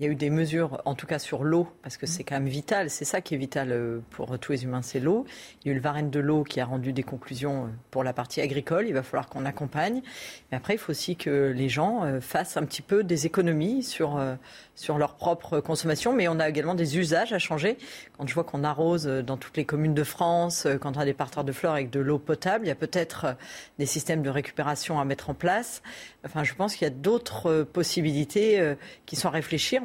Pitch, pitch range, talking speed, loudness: 150 Hz, 140-170 Hz, 245 wpm, -28 LUFS